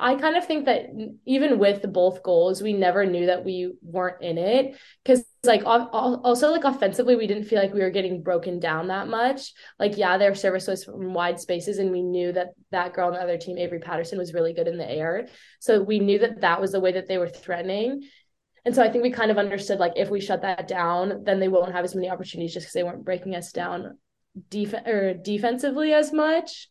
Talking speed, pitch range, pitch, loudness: 235 wpm, 180-235 Hz, 195 Hz, -24 LUFS